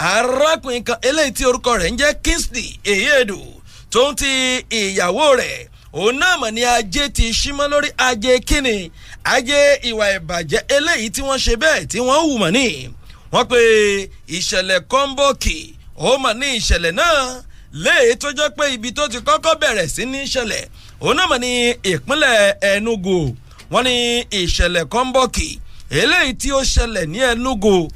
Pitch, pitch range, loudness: 250 Hz, 220-285 Hz, -16 LUFS